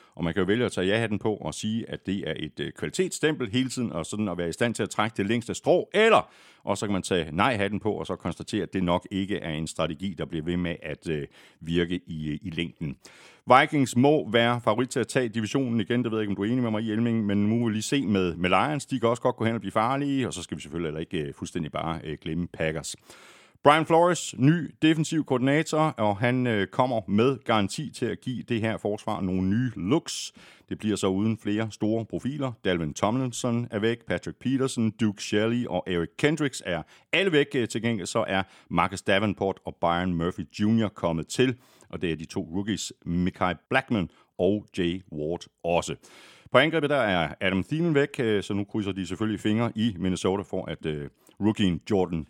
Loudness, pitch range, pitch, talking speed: -27 LUFS, 90-120 Hz, 105 Hz, 220 wpm